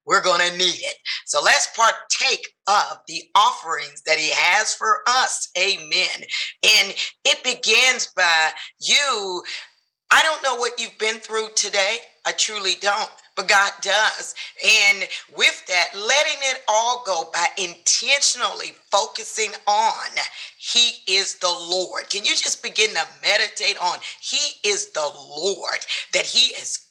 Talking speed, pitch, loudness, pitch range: 145 wpm, 230 Hz, -19 LUFS, 195-300 Hz